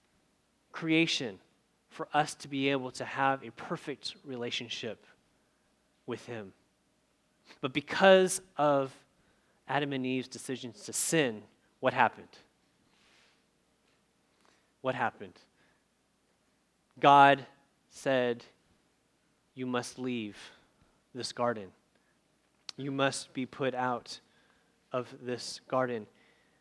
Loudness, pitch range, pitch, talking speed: -31 LUFS, 120-145 Hz, 135 Hz, 90 wpm